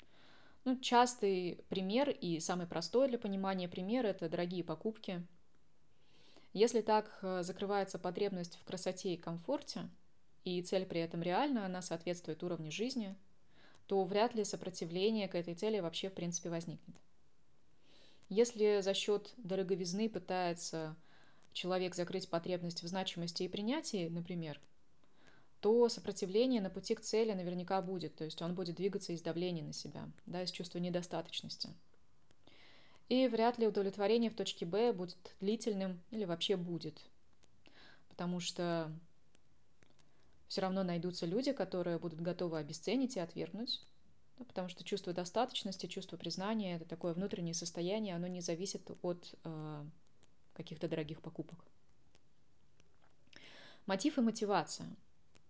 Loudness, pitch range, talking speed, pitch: -38 LUFS, 170-210 Hz, 130 wpm, 185 Hz